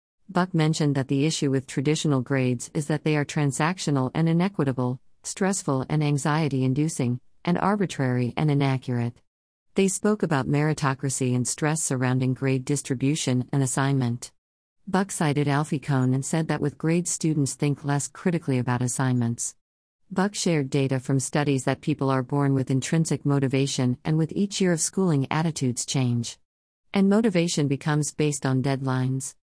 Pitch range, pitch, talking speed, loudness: 130-155 Hz, 140 Hz, 150 wpm, -25 LUFS